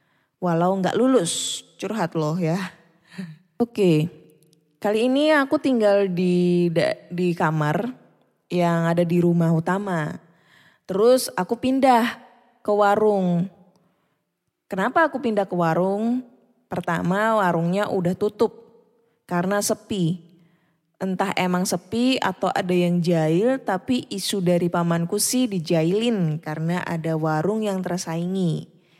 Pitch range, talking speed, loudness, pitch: 170-215 Hz, 110 wpm, -22 LUFS, 185 Hz